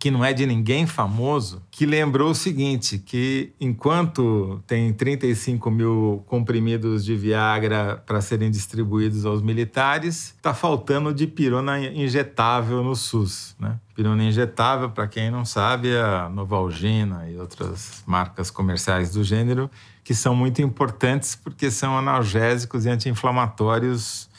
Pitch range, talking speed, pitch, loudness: 105-130 Hz, 135 wpm, 115 Hz, -22 LUFS